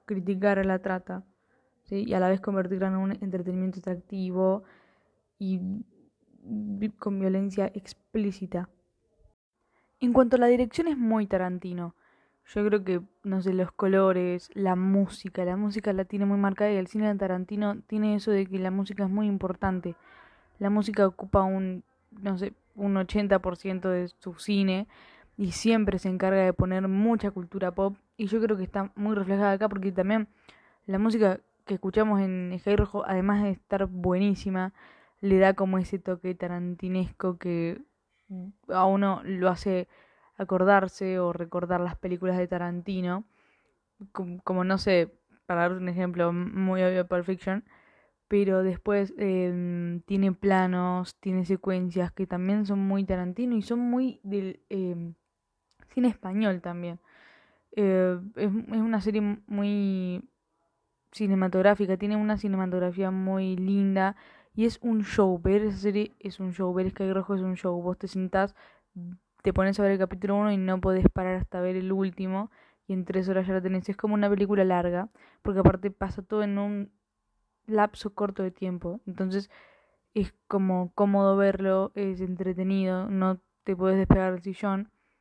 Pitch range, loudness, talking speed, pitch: 185-205 Hz, -28 LUFS, 160 wpm, 195 Hz